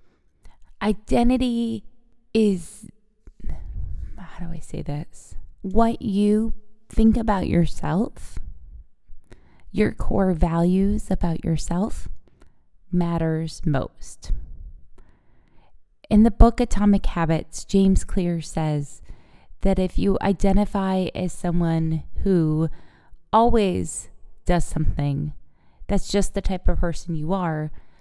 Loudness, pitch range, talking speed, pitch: -23 LUFS, 155-205 Hz, 95 wpm, 180 Hz